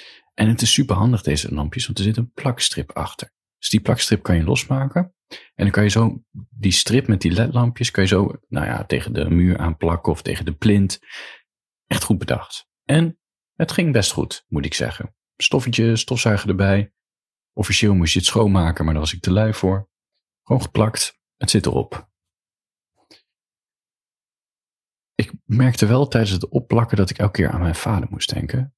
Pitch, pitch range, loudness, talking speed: 105 Hz, 90-120 Hz, -19 LUFS, 185 wpm